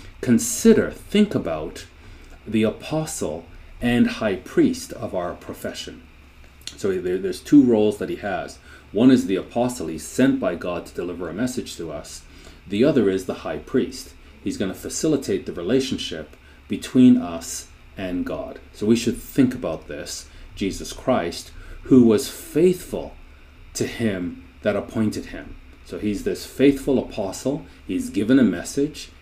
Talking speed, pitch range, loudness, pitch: 150 wpm, 80-130 Hz, -22 LUFS, 100 Hz